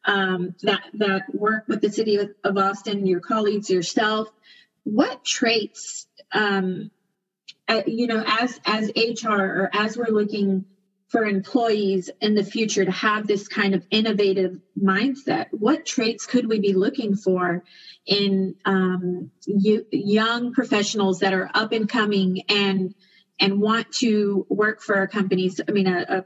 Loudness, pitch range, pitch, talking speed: -22 LUFS, 190-220 Hz, 205 Hz, 155 wpm